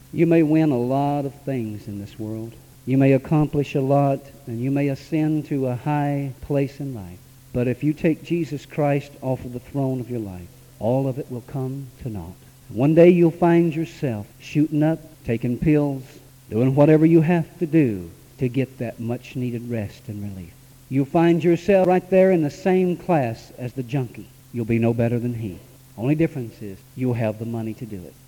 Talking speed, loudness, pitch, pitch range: 200 wpm, -21 LUFS, 135 Hz, 120-150 Hz